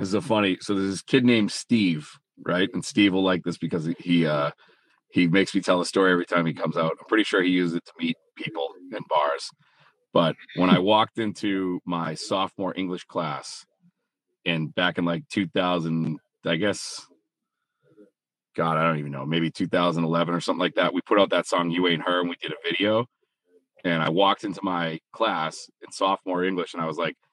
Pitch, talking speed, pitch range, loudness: 90 Hz, 205 wpm, 85-95 Hz, -24 LUFS